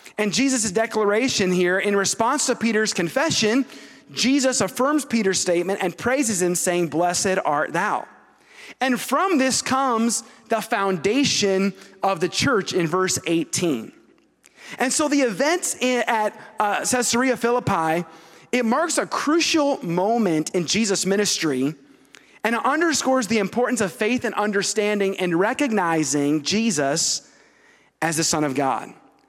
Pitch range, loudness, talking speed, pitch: 180-245 Hz, -21 LUFS, 130 wpm, 210 Hz